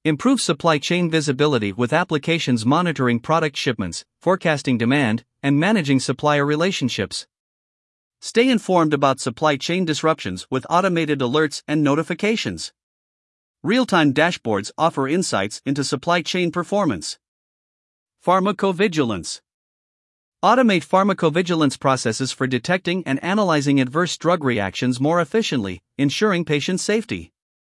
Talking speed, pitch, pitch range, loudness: 110 wpm, 155 Hz, 135-180 Hz, -20 LUFS